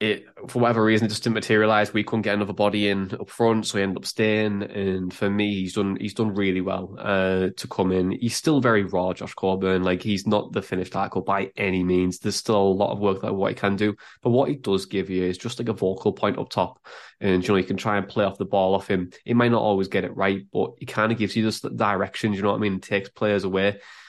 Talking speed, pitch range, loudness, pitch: 280 wpm, 95-110 Hz, -24 LUFS, 100 Hz